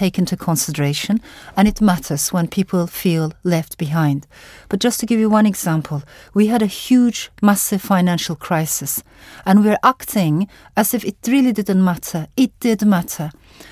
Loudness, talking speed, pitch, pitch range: -18 LUFS, 160 wpm, 190 Hz, 160-215 Hz